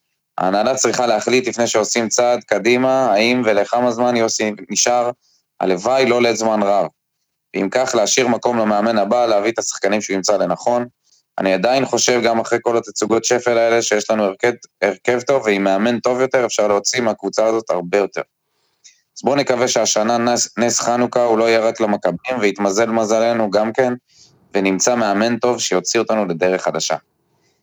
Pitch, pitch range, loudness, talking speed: 115 Hz, 105-120 Hz, -17 LUFS, 160 wpm